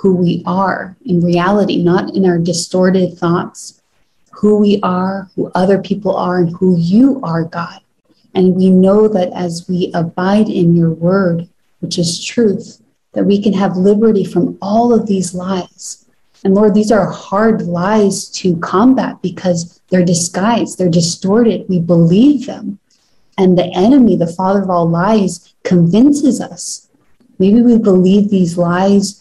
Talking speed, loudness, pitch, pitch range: 155 wpm, -13 LUFS, 190 Hz, 175-210 Hz